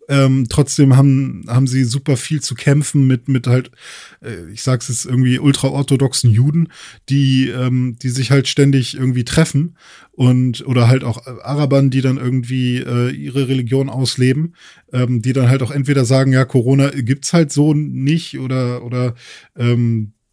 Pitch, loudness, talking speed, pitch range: 130 Hz, -15 LUFS, 160 wpm, 125-140 Hz